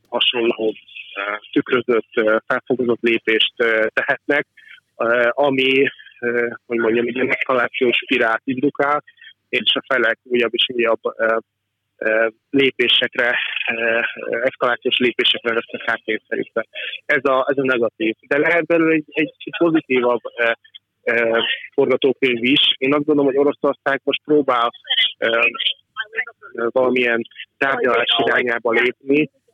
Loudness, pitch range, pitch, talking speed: -18 LUFS, 115-145 Hz, 130 Hz, 100 wpm